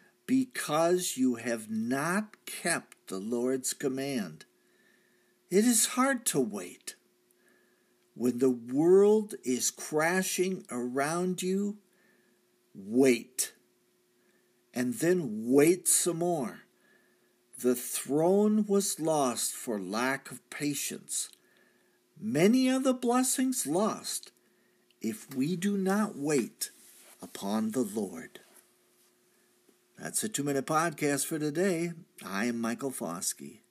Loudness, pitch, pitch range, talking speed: -29 LUFS, 155 Hz, 125-200 Hz, 105 wpm